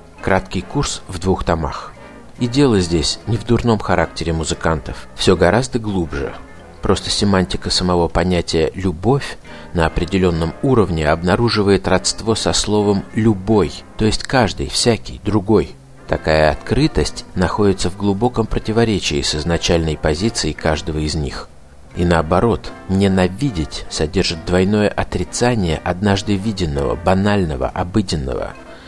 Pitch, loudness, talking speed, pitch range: 90 Hz, -17 LUFS, 115 wpm, 80-105 Hz